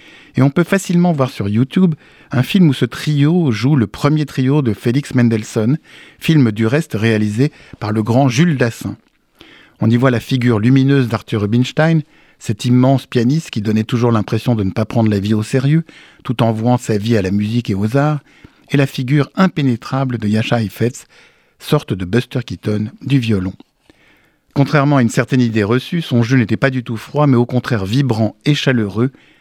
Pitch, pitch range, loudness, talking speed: 125 Hz, 115-140 Hz, -15 LUFS, 190 wpm